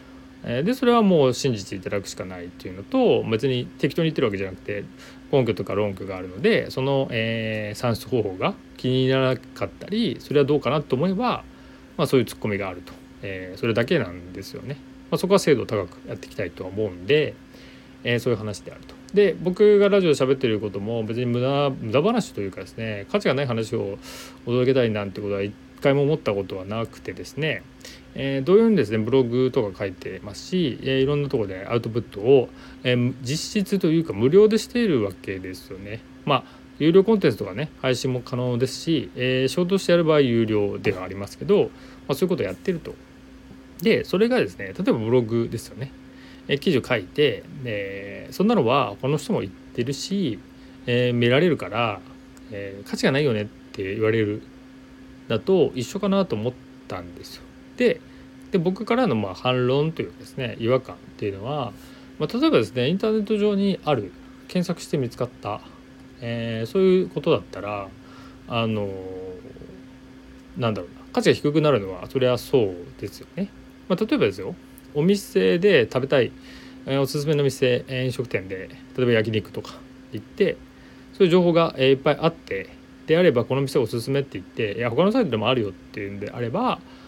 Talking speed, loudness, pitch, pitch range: 385 characters per minute, -23 LUFS, 125 Hz, 100-145 Hz